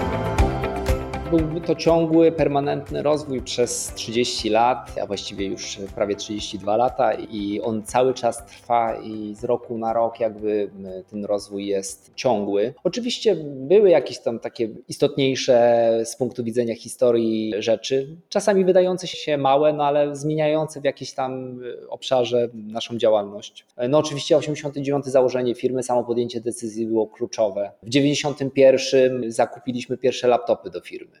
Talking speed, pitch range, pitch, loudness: 135 wpm, 110-140 Hz, 120 Hz, -22 LUFS